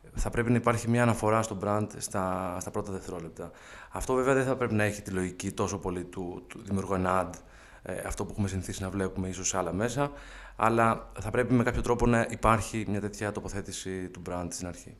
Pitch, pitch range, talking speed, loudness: 100 Hz, 95-115 Hz, 215 wpm, -30 LUFS